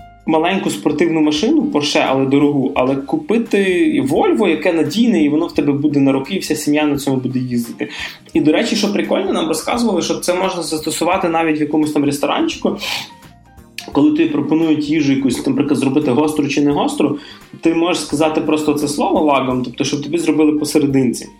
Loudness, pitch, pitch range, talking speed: -16 LUFS, 155 Hz, 145-185 Hz, 180 wpm